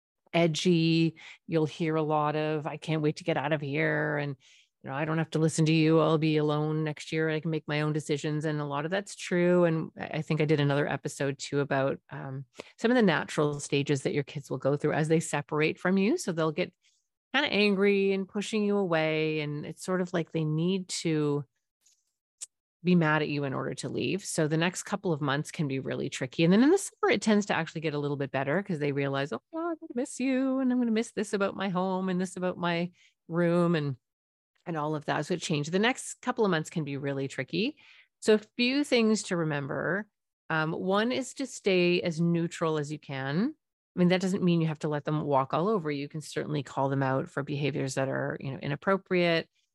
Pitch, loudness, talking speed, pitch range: 160 Hz, -29 LUFS, 240 wpm, 150-185 Hz